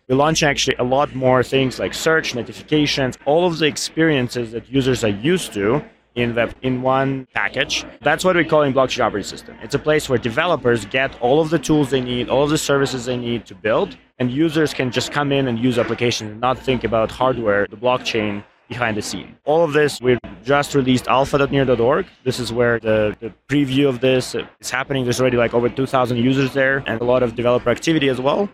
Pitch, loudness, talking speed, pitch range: 130 Hz, -19 LUFS, 220 wpm, 120-140 Hz